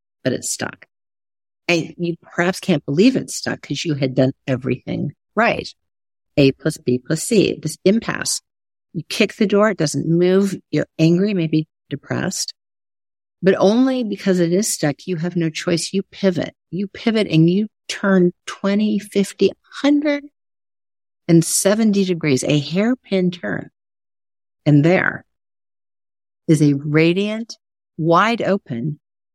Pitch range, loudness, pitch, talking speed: 140-195 Hz, -19 LUFS, 170 Hz, 135 wpm